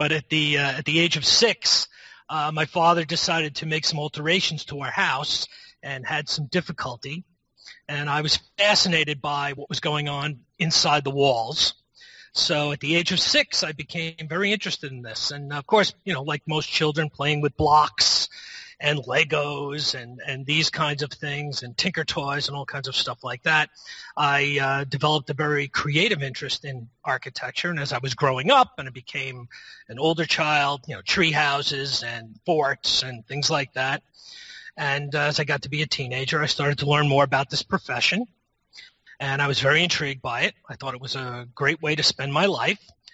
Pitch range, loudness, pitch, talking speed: 140-155 Hz, -23 LUFS, 145 Hz, 200 wpm